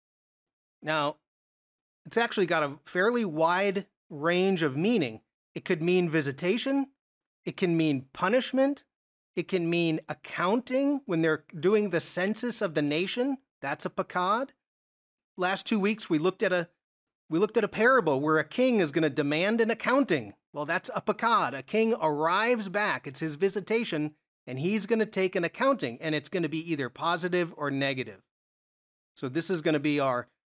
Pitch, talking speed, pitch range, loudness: 180 Hz, 175 wpm, 155-210 Hz, -28 LUFS